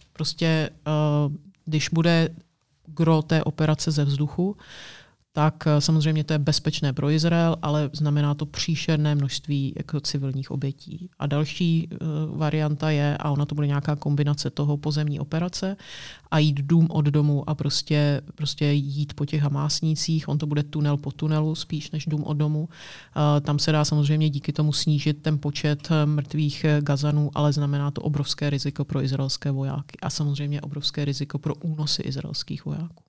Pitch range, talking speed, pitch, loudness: 145-155 Hz, 160 wpm, 150 Hz, -24 LUFS